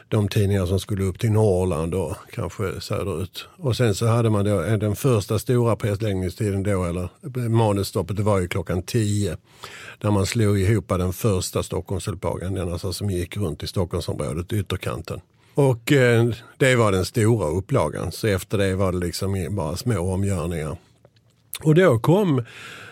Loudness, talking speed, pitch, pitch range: -23 LUFS, 160 wpm, 100 Hz, 95-115 Hz